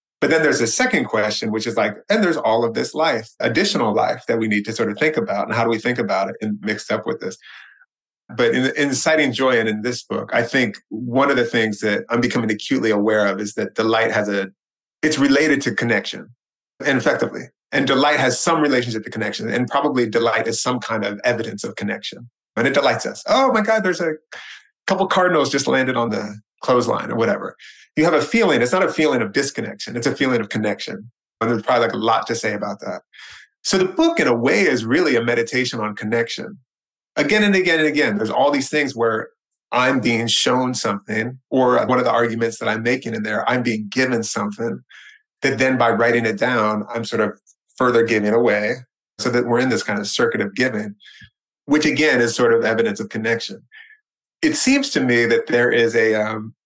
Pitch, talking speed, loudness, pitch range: 120 Hz, 220 wpm, -19 LUFS, 110-150 Hz